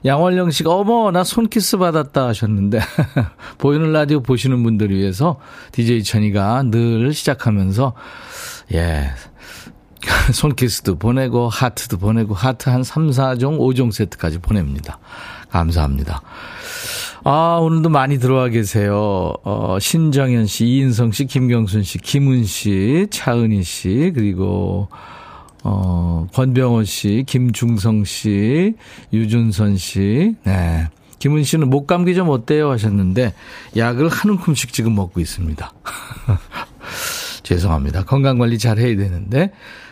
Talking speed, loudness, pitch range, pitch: 255 characters per minute, -17 LUFS, 100-140 Hz, 120 Hz